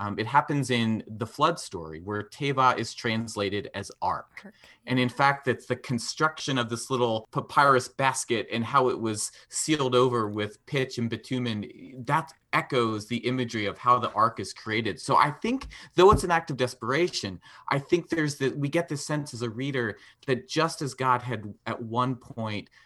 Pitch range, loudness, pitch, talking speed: 115-140 Hz, -27 LUFS, 125 Hz, 190 wpm